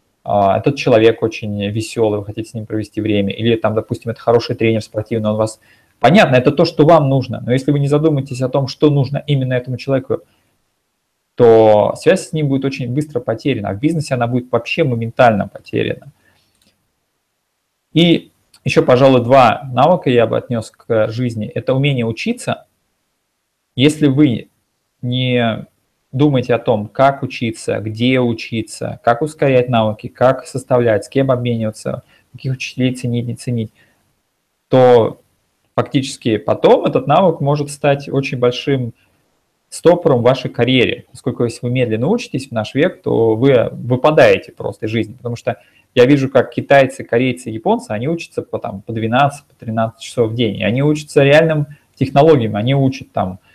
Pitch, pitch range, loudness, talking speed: 125 Hz, 110-140 Hz, -15 LUFS, 160 wpm